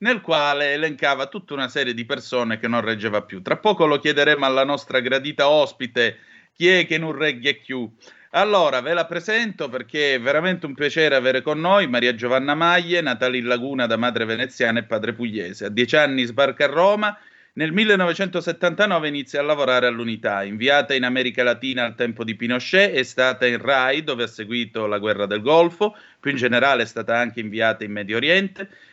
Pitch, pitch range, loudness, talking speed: 135 Hz, 120-160 Hz, -20 LUFS, 190 wpm